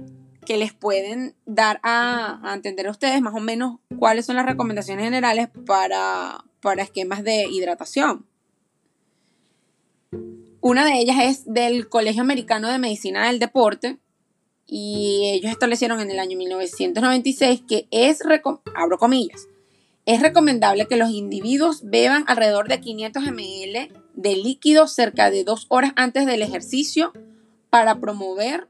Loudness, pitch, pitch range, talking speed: -20 LUFS, 225 Hz, 200-255 Hz, 135 wpm